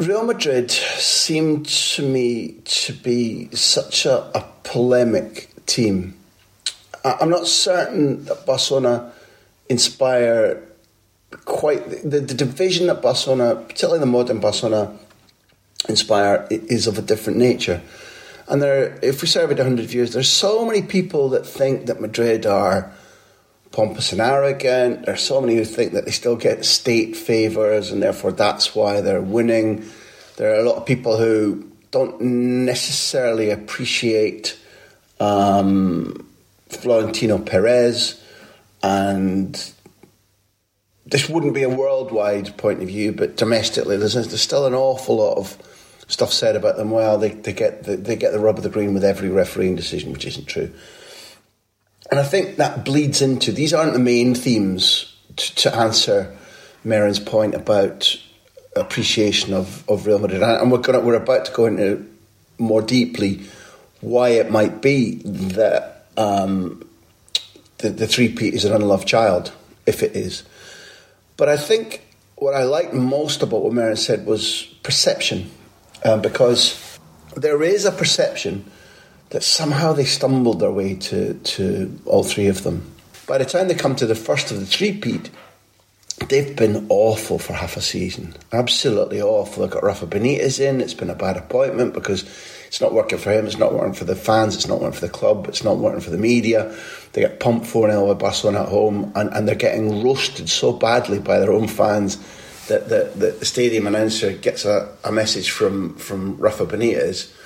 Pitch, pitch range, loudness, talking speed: 120 Hz, 105-140 Hz, -19 LUFS, 165 wpm